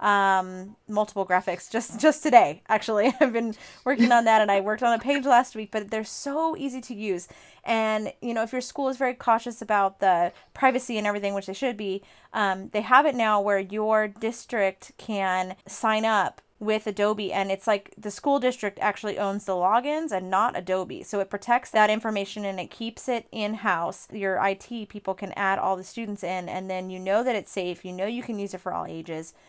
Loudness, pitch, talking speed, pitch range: -25 LUFS, 210 Hz, 215 wpm, 195-235 Hz